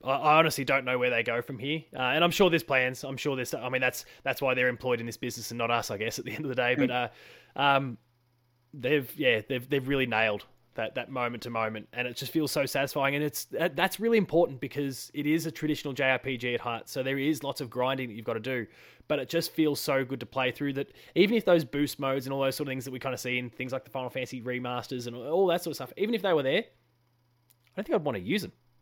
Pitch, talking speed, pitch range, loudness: 130 Hz, 280 wpm, 125-145 Hz, -29 LUFS